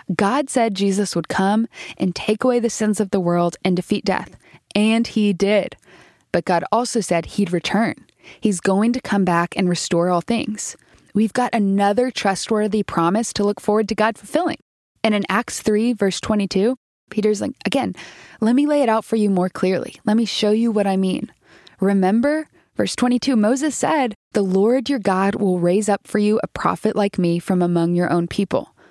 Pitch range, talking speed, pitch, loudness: 190-225 Hz, 195 wpm, 210 Hz, -20 LUFS